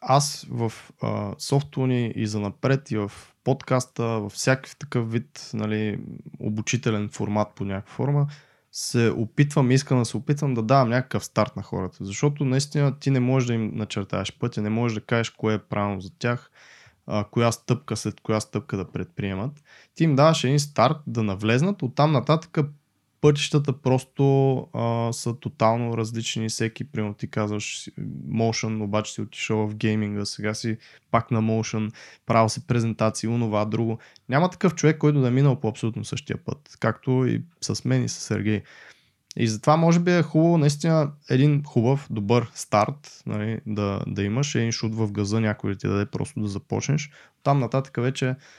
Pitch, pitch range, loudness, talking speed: 120 Hz, 110-140 Hz, -24 LUFS, 175 wpm